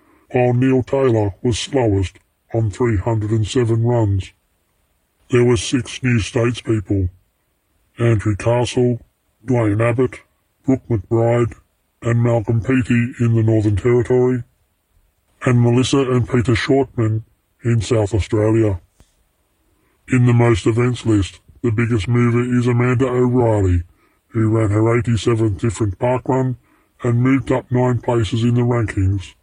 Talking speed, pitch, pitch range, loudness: 120 wpm, 115 Hz, 105-125 Hz, -18 LUFS